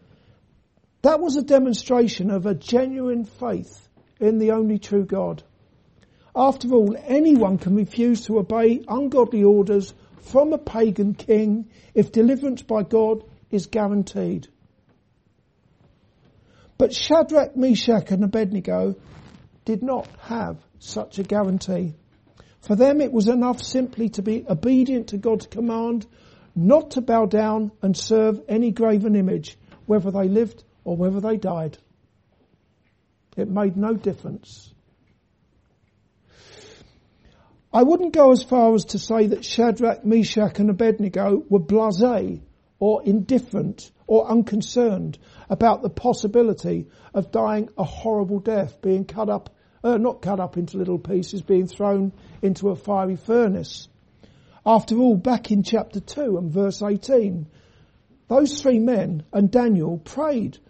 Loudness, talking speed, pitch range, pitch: -21 LUFS, 130 wpm, 195-235 Hz, 210 Hz